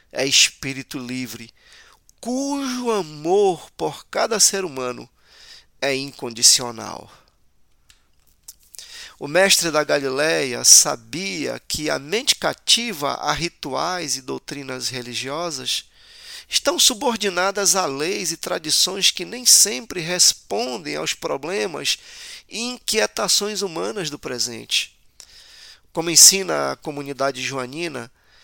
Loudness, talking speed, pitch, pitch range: -18 LUFS, 100 wpm, 175 Hz, 135-220 Hz